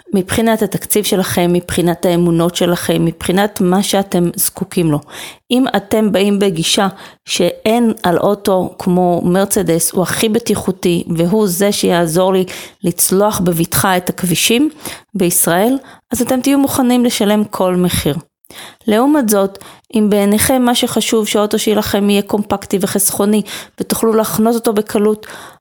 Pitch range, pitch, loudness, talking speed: 180-220 Hz, 200 Hz, -14 LUFS, 125 wpm